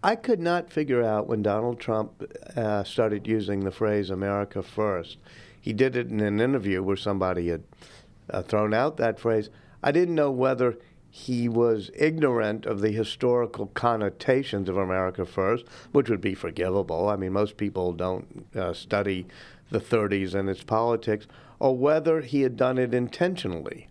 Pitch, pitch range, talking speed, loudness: 110 Hz, 100-125 Hz, 165 wpm, -26 LUFS